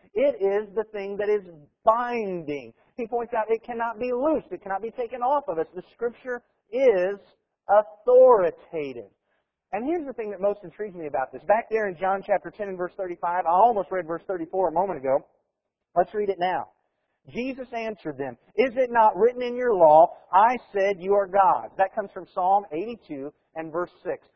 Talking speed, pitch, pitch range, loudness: 195 wpm, 205 Hz, 180-240 Hz, -24 LUFS